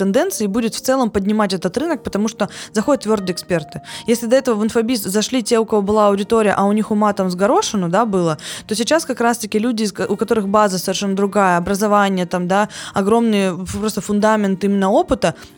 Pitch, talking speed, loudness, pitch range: 210 Hz, 195 wpm, -17 LUFS, 195-230 Hz